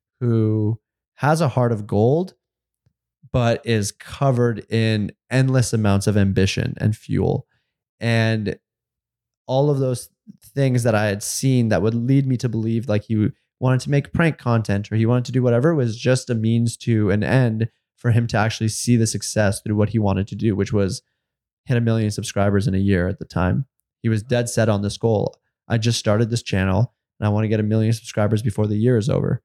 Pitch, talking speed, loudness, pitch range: 115 Hz, 205 wpm, -20 LUFS, 105-125 Hz